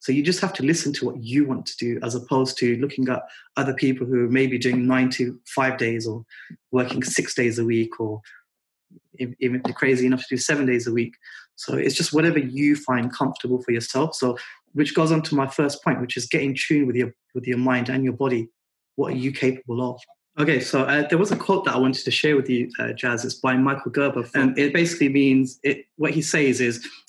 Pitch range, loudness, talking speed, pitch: 125-145 Hz, -22 LUFS, 240 wpm, 130 Hz